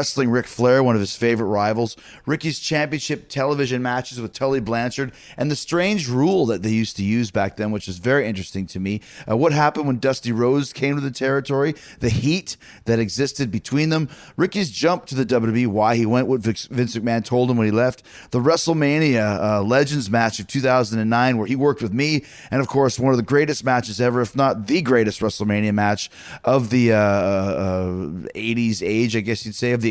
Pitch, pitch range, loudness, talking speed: 125 Hz, 110-140 Hz, -20 LUFS, 205 wpm